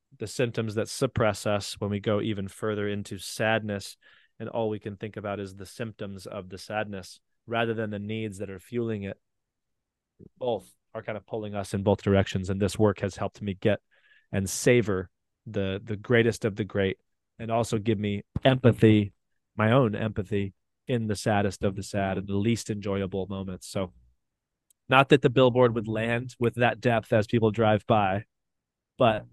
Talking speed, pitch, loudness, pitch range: 185 wpm, 105 Hz, -27 LUFS, 100-115 Hz